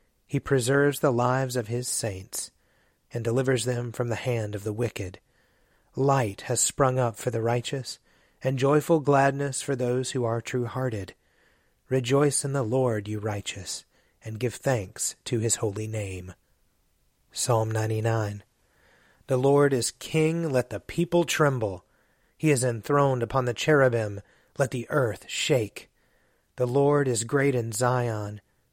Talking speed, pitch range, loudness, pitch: 150 wpm, 110-135 Hz, -26 LUFS, 125 Hz